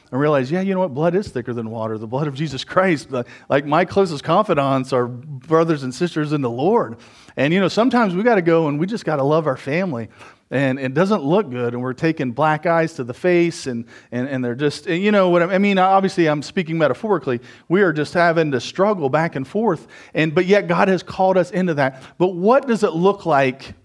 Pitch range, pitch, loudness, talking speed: 130-185 Hz, 160 Hz, -19 LUFS, 240 wpm